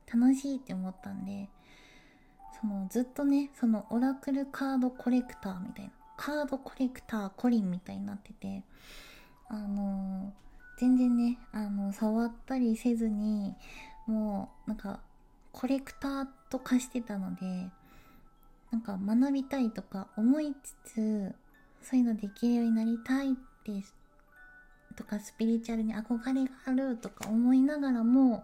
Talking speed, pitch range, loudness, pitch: 295 characters per minute, 200-260 Hz, -32 LUFS, 230 Hz